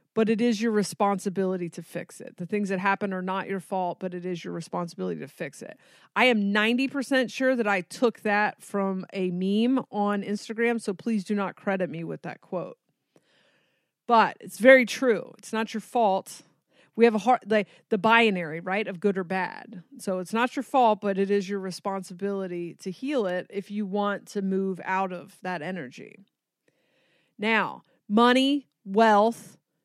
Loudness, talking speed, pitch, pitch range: -26 LUFS, 185 wpm, 205 Hz, 190-230 Hz